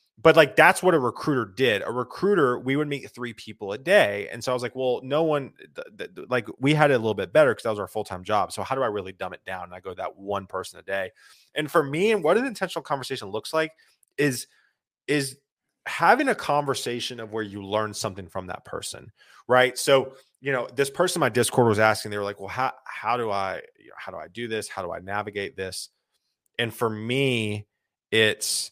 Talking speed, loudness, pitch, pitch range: 240 wpm, -24 LUFS, 125 Hz, 110-145 Hz